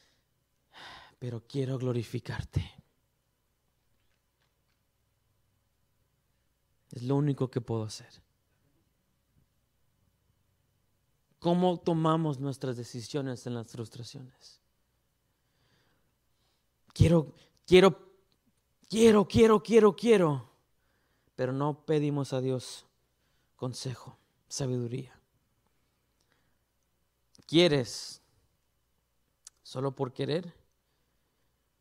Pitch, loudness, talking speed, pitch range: 130 Hz, -28 LUFS, 60 wpm, 115-150 Hz